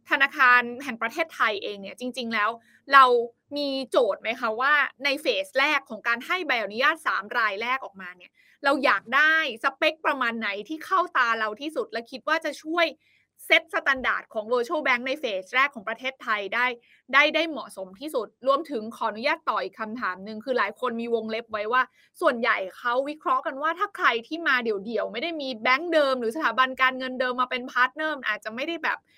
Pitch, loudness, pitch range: 260 Hz, -24 LUFS, 230-300 Hz